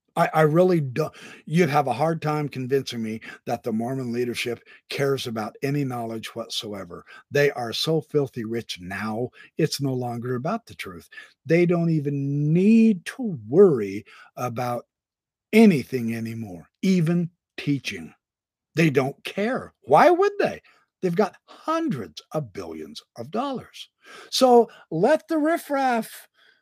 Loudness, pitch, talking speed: -23 LUFS, 155 Hz, 135 wpm